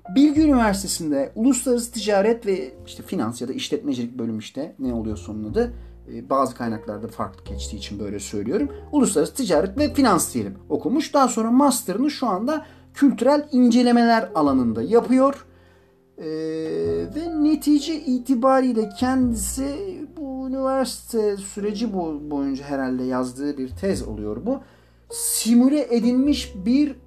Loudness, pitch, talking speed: -22 LUFS, 230 Hz, 125 wpm